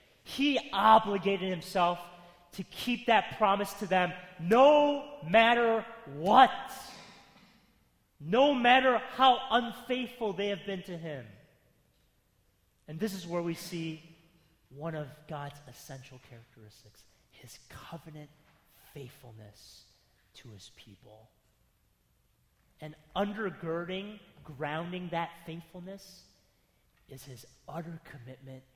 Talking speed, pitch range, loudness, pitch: 100 wpm, 145-210 Hz, -28 LUFS, 170 Hz